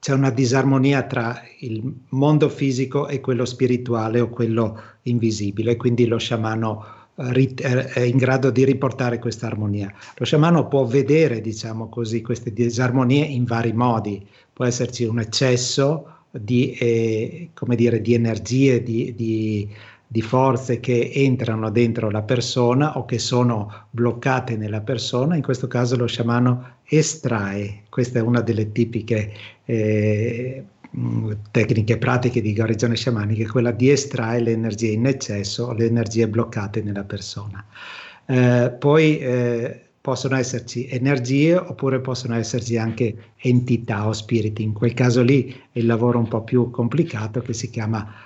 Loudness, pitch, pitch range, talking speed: -21 LUFS, 120 Hz, 115-130 Hz, 145 wpm